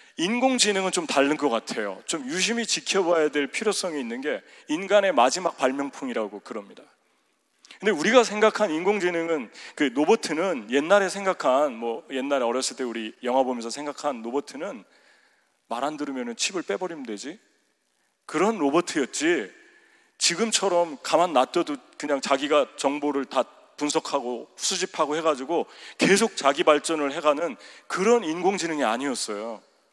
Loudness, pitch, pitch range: -24 LUFS, 160 Hz, 140-210 Hz